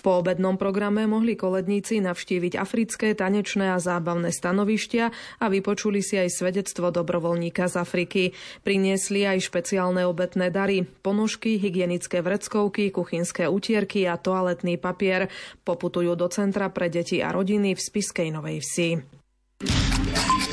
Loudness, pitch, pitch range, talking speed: -25 LUFS, 185 Hz, 175-205 Hz, 125 wpm